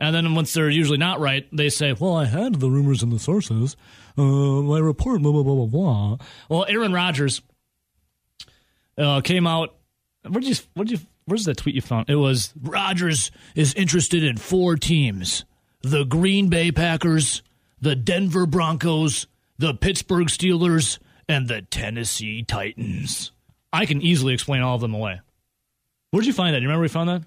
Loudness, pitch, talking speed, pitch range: -21 LUFS, 145 Hz, 175 wpm, 125-170 Hz